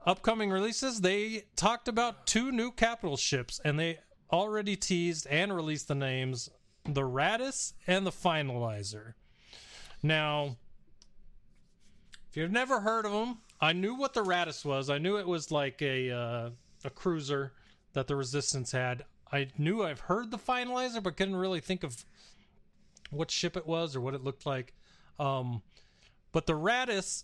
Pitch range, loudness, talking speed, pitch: 140-205 Hz, -32 LUFS, 155 wpm, 165 Hz